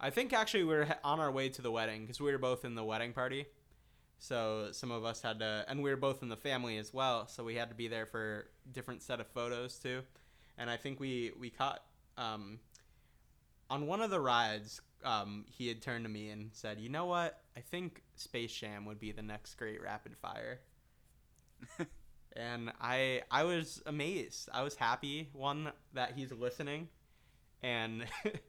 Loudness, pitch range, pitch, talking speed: -39 LUFS, 110-140 Hz, 120 Hz, 195 wpm